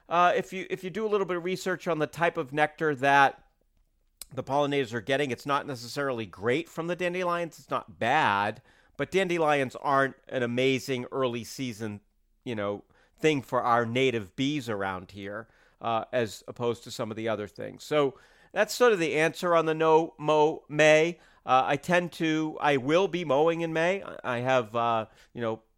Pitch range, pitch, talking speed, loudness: 120-165 Hz, 140 Hz, 190 wpm, -27 LUFS